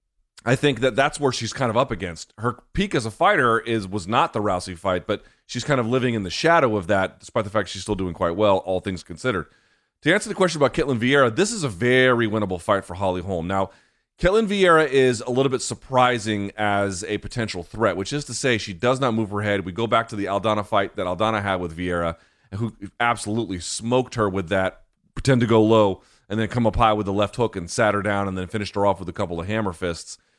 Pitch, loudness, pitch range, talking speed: 110 Hz, -22 LUFS, 95-125 Hz, 250 wpm